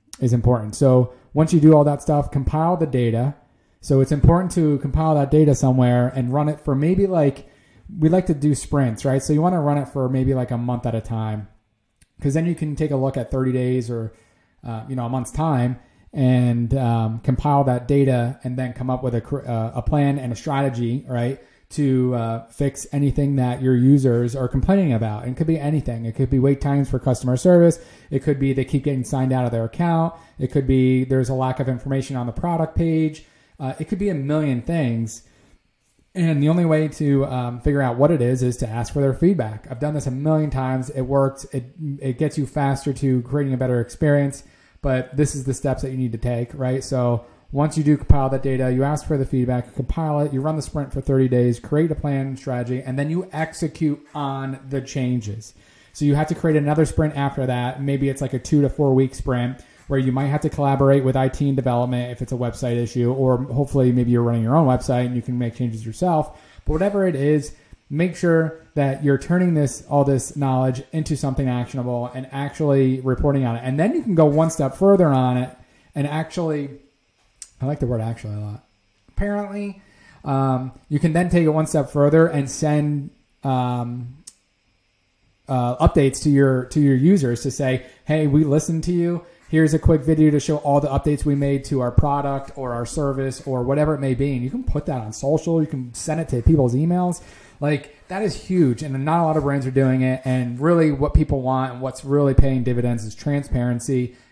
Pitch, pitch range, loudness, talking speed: 135 Hz, 125-150 Hz, -21 LUFS, 225 wpm